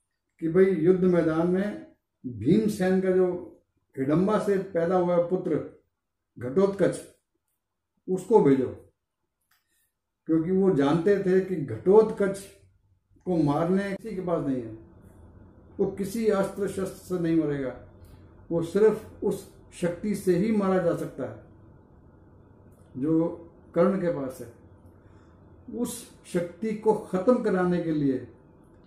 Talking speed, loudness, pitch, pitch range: 125 wpm, -26 LUFS, 170 Hz, 125-190 Hz